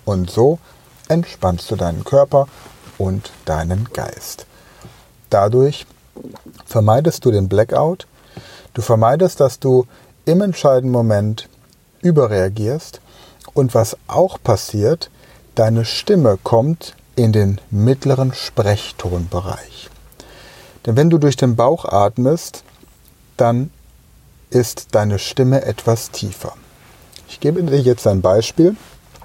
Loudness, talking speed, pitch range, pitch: -16 LUFS, 105 wpm, 105-135 Hz, 120 Hz